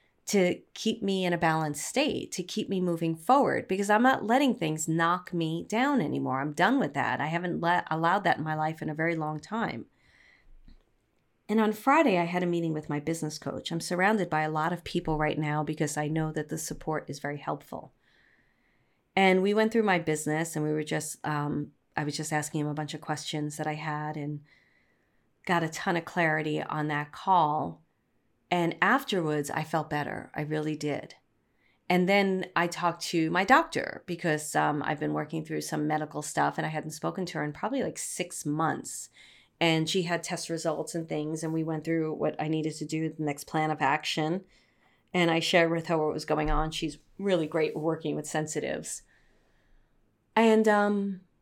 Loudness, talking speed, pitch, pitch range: -29 LUFS, 200 wpm, 160 Hz, 150-180 Hz